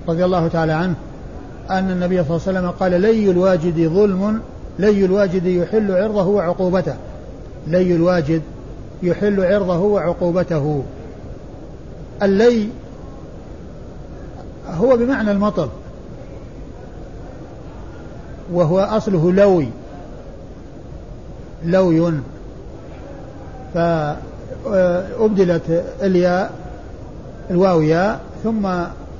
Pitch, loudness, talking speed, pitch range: 180 Hz, -17 LUFS, 75 wpm, 170-195 Hz